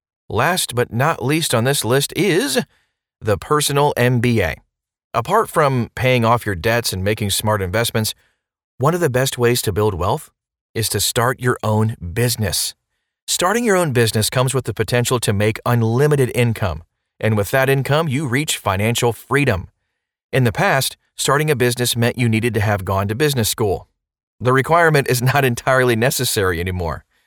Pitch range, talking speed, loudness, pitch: 110-135 Hz, 170 wpm, -18 LUFS, 120 Hz